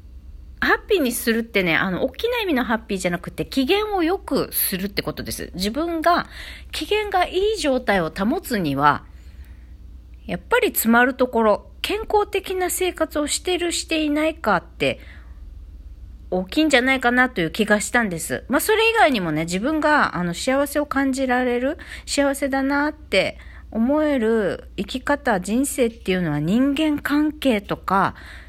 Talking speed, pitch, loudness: 320 characters per minute, 250 Hz, -21 LUFS